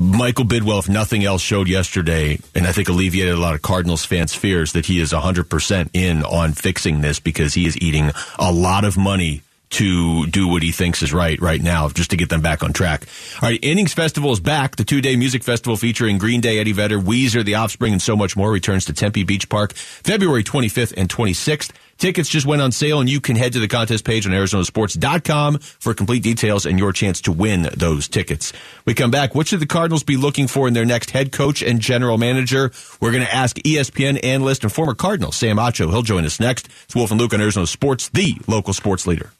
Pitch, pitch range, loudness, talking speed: 105 Hz, 90-125 Hz, -18 LUFS, 230 wpm